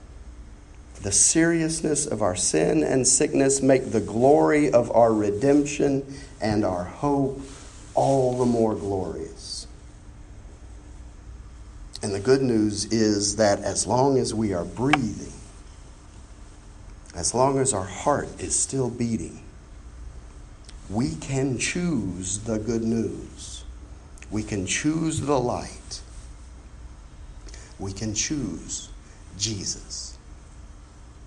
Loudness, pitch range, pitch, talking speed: -23 LUFS, 85-130 Hz, 100 Hz, 105 wpm